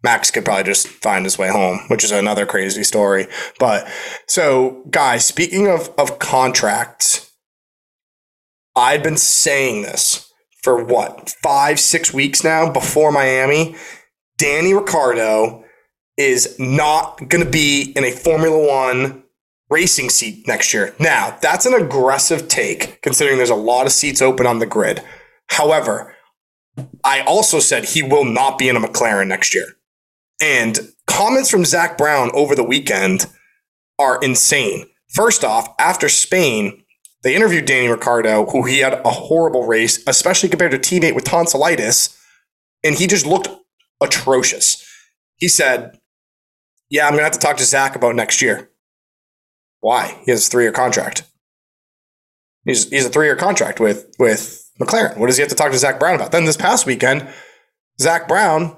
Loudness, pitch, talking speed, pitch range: -15 LUFS, 150 Hz, 160 wpm, 130-180 Hz